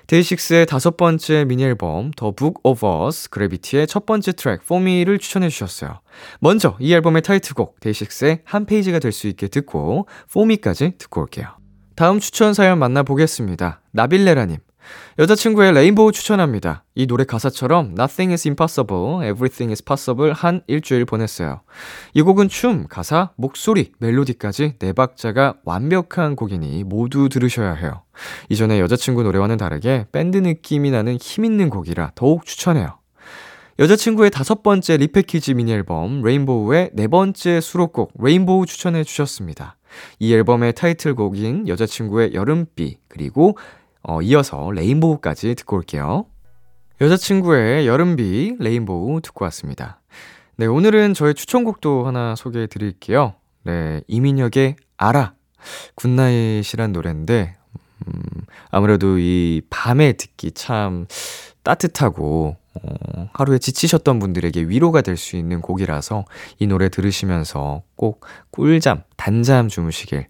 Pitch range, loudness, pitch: 105-165 Hz, -17 LUFS, 130 Hz